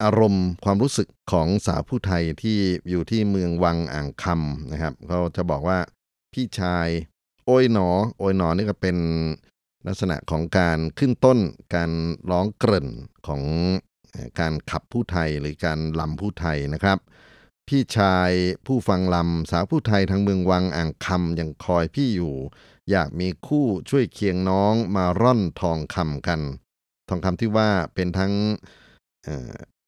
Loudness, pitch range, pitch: -23 LUFS, 80-100 Hz, 90 Hz